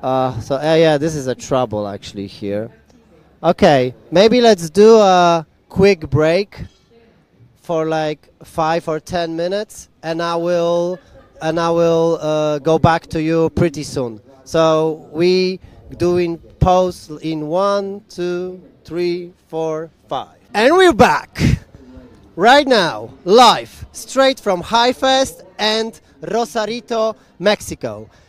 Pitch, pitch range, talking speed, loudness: 165 Hz, 150-190 Hz, 125 wpm, -16 LUFS